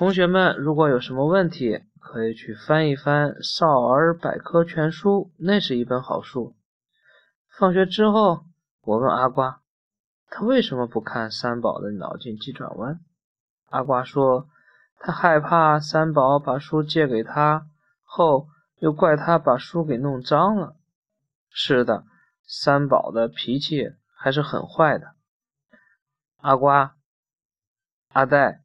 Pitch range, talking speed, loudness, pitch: 130-170 Hz, 185 characters per minute, -21 LUFS, 150 Hz